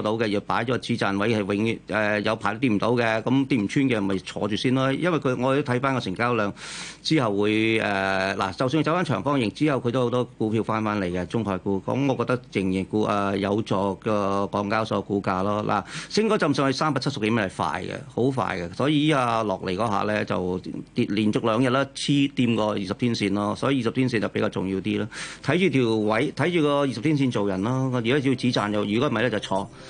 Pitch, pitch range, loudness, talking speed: 110 Hz, 100-130 Hz, -24 LUFS, 345 characters per minute